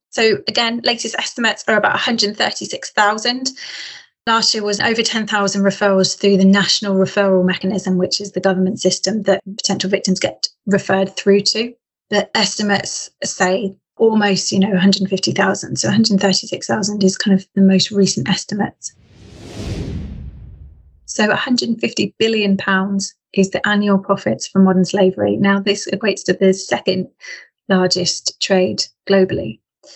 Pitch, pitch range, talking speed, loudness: 195 Hz, 190-205 Hz, 130 wpm, -16 LUFS